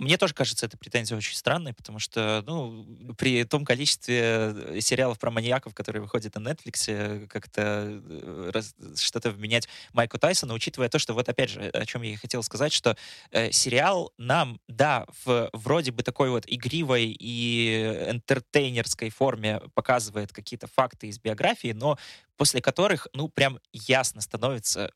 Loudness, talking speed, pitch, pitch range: -26 LUFS, 155 wpm, 120 Hz, 110-130 Hz